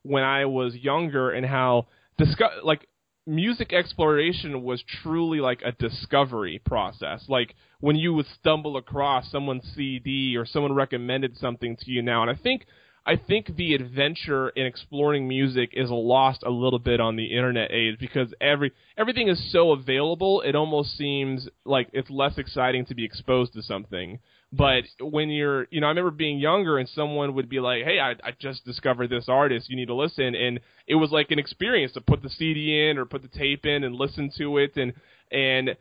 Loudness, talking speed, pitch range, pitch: -25 LUFS, 195 wpm, 125-150 Hz, 135 Hz